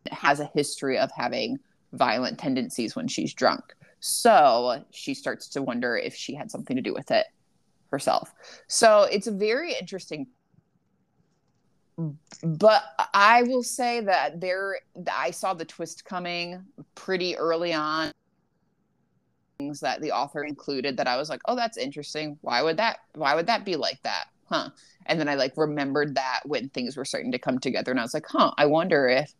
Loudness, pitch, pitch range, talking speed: -25 LUFS, 170 Hz, 150-210 Hz, 175 wpm